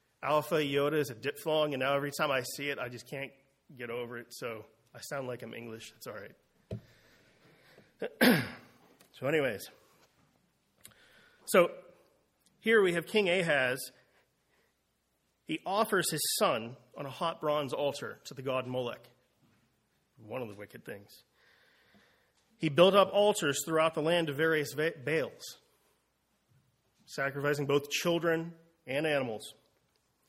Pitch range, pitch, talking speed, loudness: 125-165 Hz, 145 Hz, 135 wpm, -31 LUFS